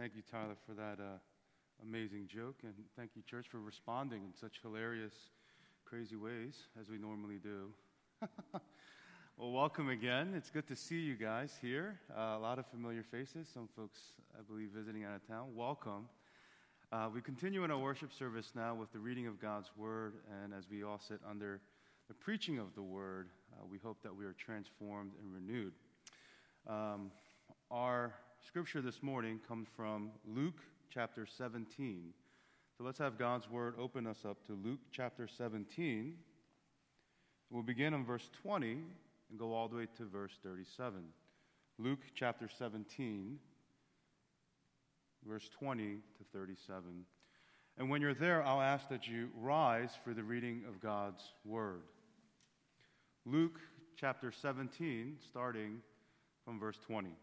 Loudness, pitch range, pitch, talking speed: -44 LUFS, 105-130 Hz, 115 Hz, 155 wpm